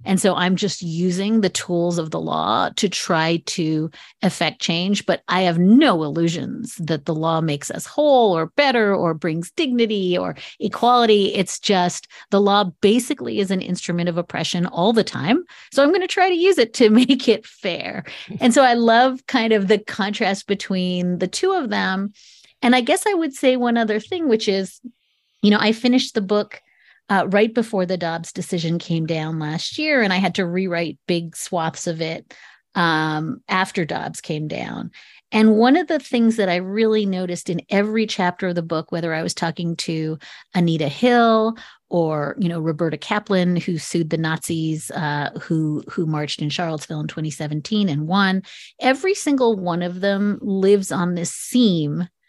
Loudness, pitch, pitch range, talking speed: -20 LUFS, 185 Hz, 170-225 Hz, 185 wpm